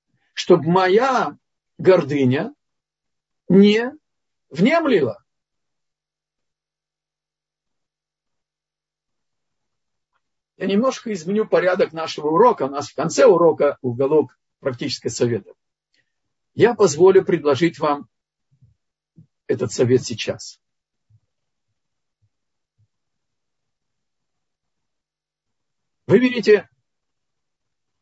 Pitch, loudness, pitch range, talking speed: 180 Hz, -18 LUFS, 130-210 Hz, 60 wpm